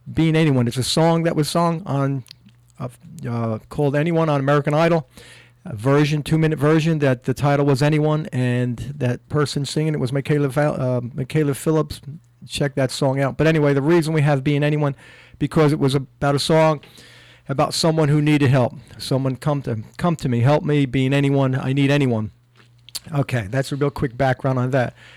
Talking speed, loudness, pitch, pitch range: 190 wpm, -20 LUFS, 140 Hz, 130-150 Hz